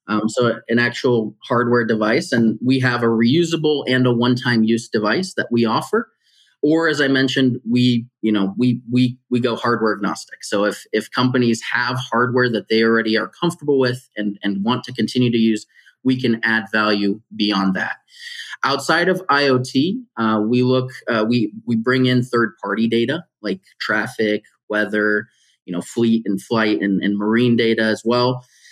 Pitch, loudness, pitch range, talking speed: 120 Hz, -18 LUFS, 110-125 Hz, 180 wpm